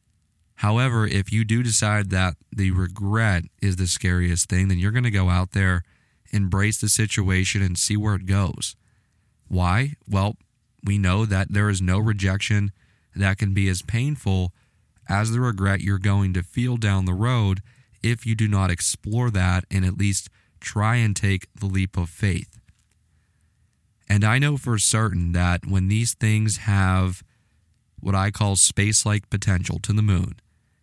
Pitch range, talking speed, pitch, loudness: 95-110 Hz, 165 wpm, 100 Hz, -22 LUFS